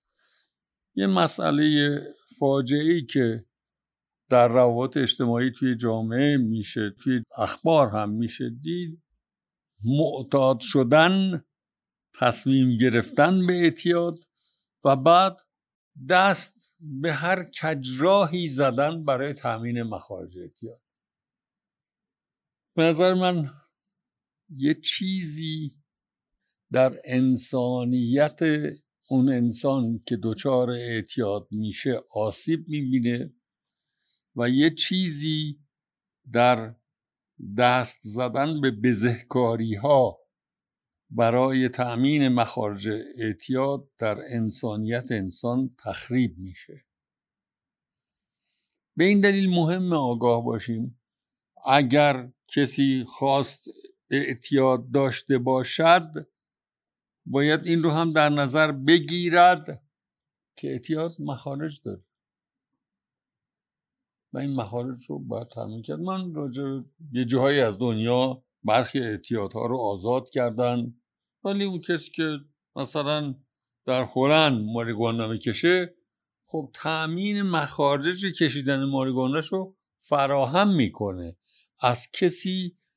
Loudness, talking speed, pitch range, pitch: -24 LUFS, 90 wpm, 120-160 Hz, 135 Hz